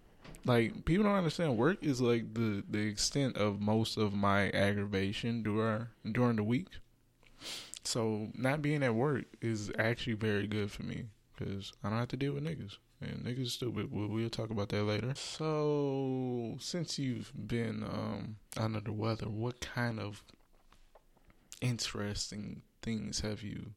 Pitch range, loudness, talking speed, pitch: 105-125 Hz, -35 LUFS, 160 wpm, 110 Hz